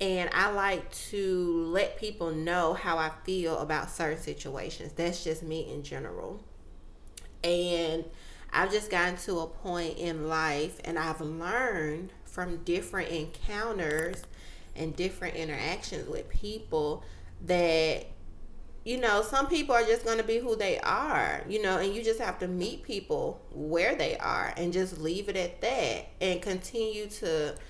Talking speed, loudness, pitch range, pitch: 155 wpm, -31 LUFS, 160-205 Hz, 175 Hz